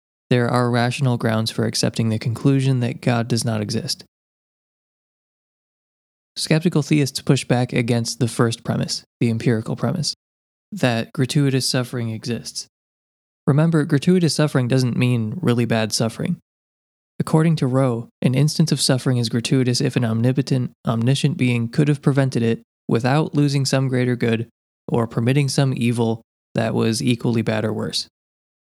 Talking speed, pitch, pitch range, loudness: 145 wpm, 125 Hz, 115-140 Hz, -20 LUFS